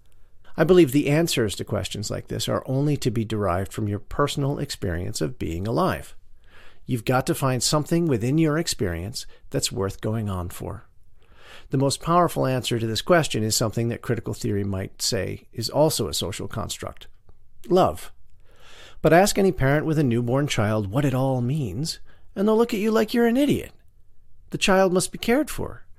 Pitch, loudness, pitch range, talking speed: 130 Hz, -23 LUFS, 110-160 Hz, 185 wpm